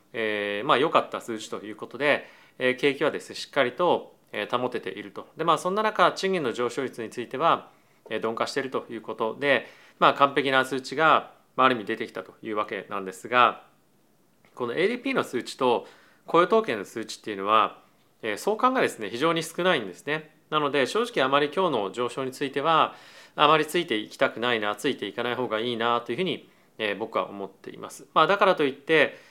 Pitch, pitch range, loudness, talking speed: 140 Hz, 120-165 Hz, -25 LUFS, 415 characters per minute